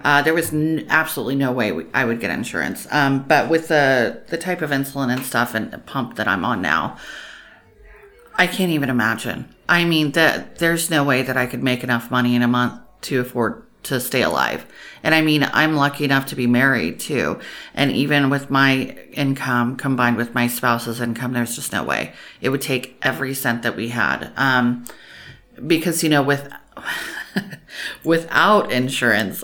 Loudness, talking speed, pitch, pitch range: -19 LUFS, 190 wpm, 135 Hz, 120-155 Hz